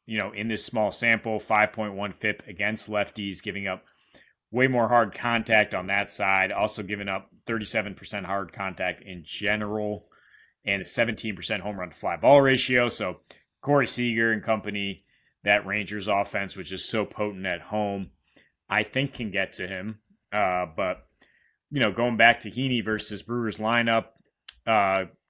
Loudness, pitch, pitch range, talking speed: -26 LUFS, 105 Hz, 100-115 Hz, 160 wpm